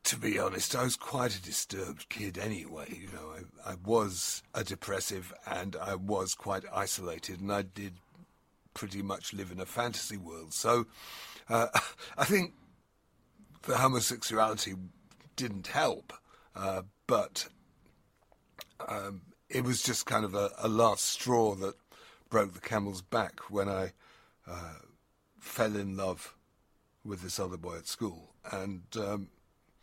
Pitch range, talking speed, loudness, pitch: 95-115 Hz, 145 wpm, -33 LUFS, 100 Hz